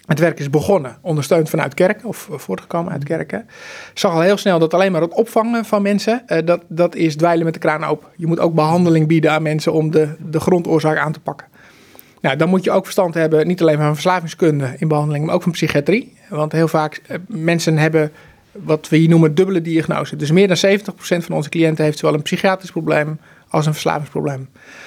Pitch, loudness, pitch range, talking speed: 165 Hz, -17 LUFS, 155-185 Hz, 210 wpm